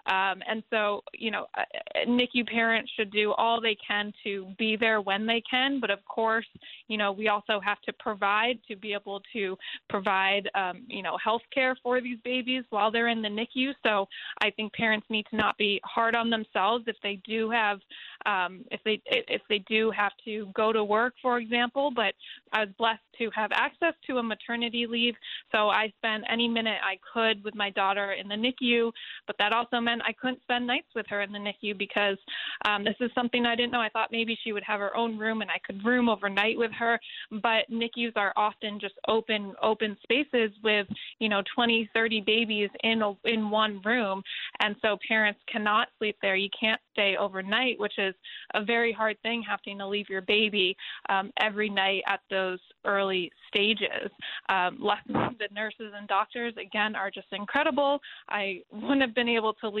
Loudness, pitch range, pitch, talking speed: -28 LUFS, 205-235 Hz, 220 Hz, 200 wpm